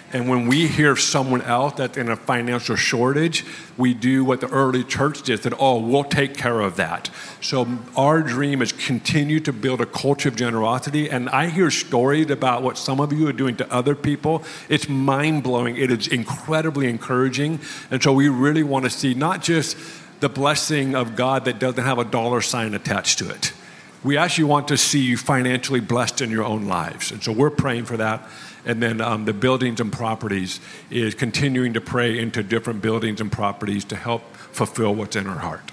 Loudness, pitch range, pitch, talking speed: -21 LUFS, 115-145 Hz, 130 Hz, 200 wpm